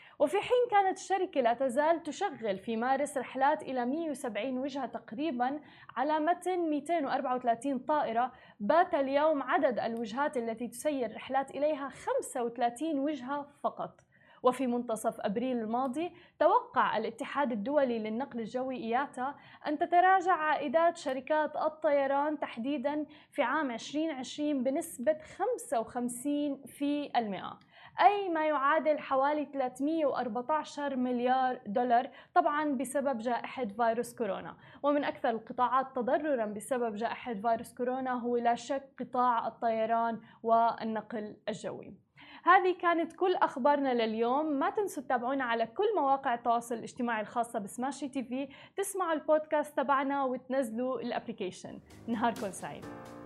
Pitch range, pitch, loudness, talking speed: 240-300 Hz, 270 Hz, -32 LUFS, 115 wpm